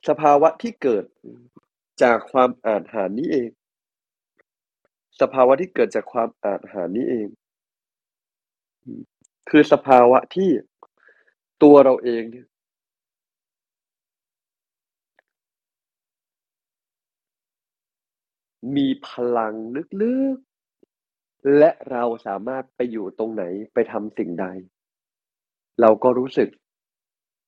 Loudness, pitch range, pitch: -19 LUFS, 115-155 Hz, 130 Hz